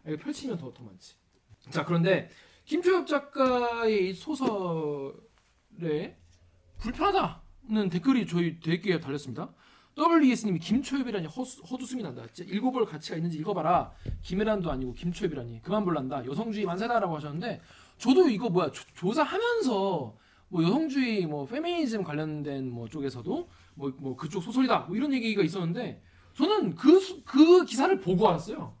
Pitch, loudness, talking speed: 190 Hz, -28 LUFS, 335 characters per minute